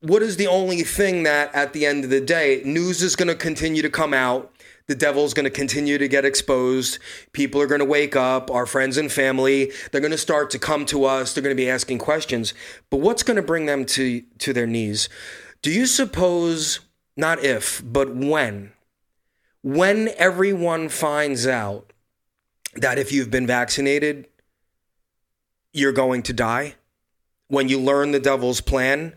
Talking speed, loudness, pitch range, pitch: 180 wpm, -20 LUFS, 130-155 Hz, 140 Hz